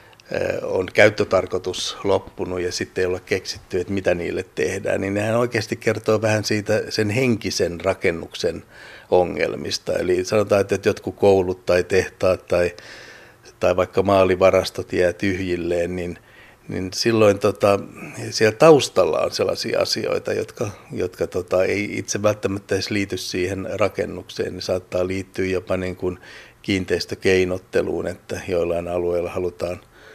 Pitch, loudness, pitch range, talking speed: 95 Hz, -21 LUFS, 90-110 Hz, 130 wpm